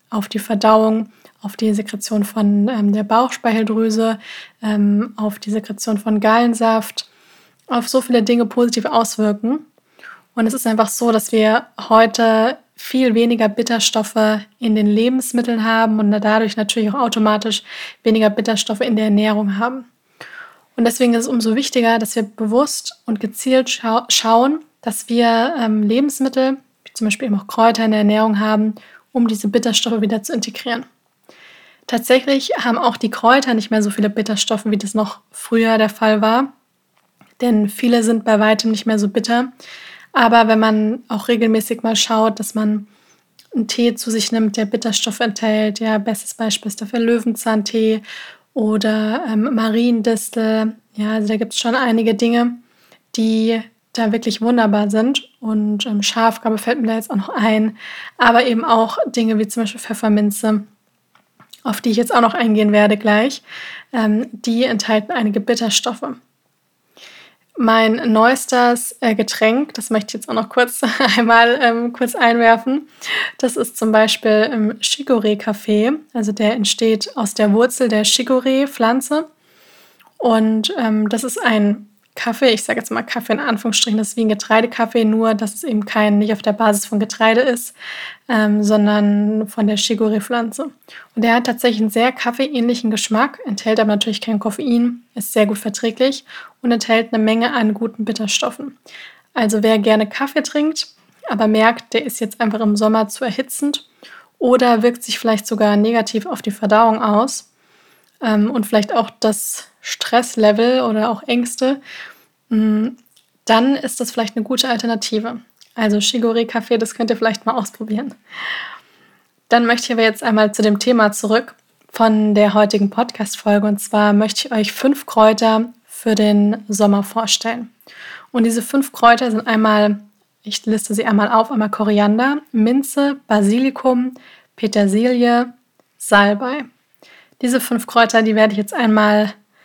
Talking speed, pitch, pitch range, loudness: 155 wpm, 225 Hz, 215-240 Hz, -16 LUFS